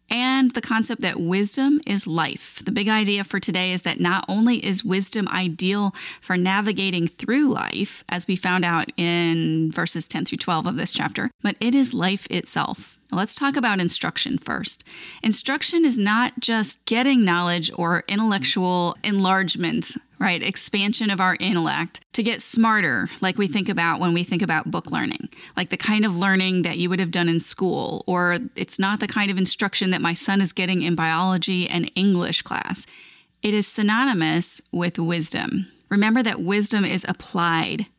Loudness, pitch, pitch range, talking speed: -21 LUFS, 195 Hz, 175-215 Hz, 175 wpm